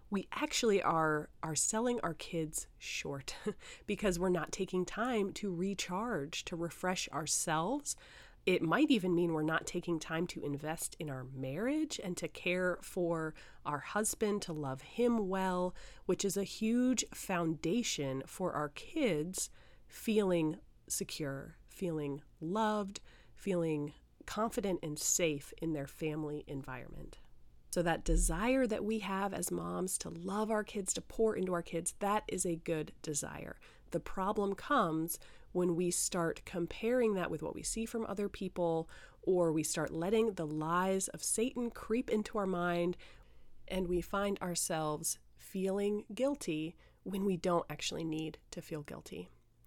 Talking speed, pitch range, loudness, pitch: 150 wpm, 160-205 Hz, -36 LUFS, 180 Hz